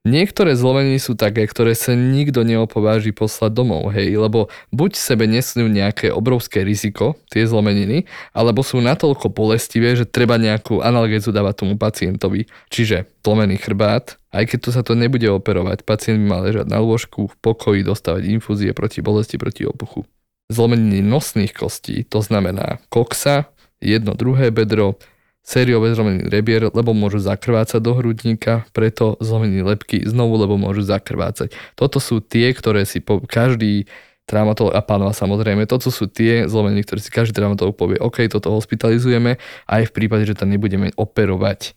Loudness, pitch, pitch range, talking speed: -17 LUFS, 110 Hz, 105-115 Hz, 155 wpm